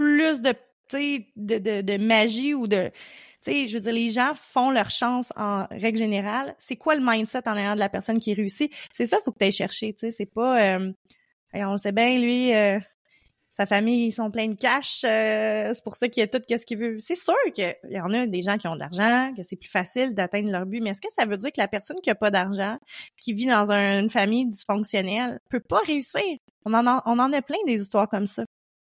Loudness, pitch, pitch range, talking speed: -24 LUFS, 225 Hz, 205-250 Hz, 250 wpm